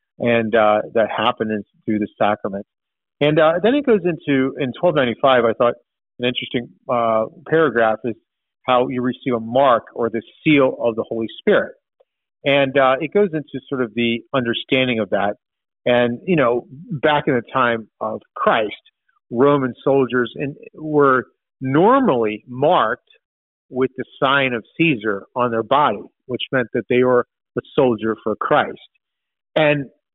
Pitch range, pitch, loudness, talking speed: 115-145 Hz, 125 Hz, -19 LUFS, 160 wpm